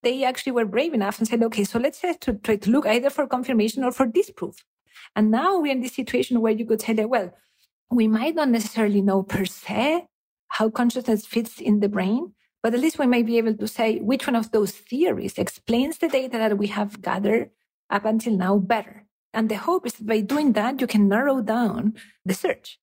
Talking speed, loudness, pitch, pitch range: 220 wpm, -23 LUFS, 225 Hz, 215-255 Hz